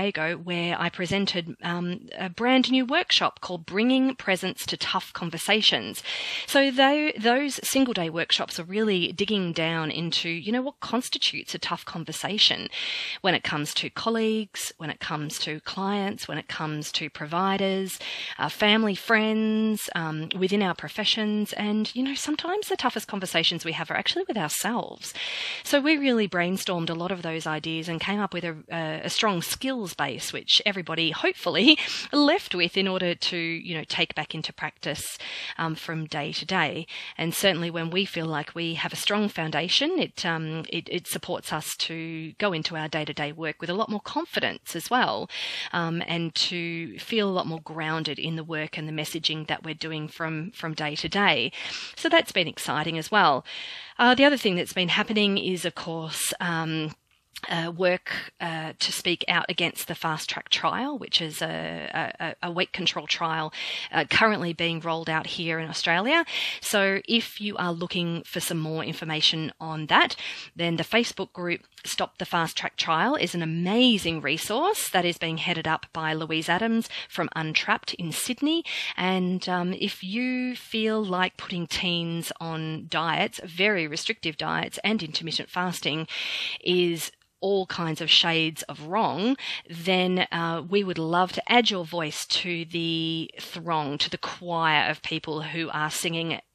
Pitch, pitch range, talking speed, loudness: 175 Hz, 160-205 Hz, 175 wpm, -26 LUFS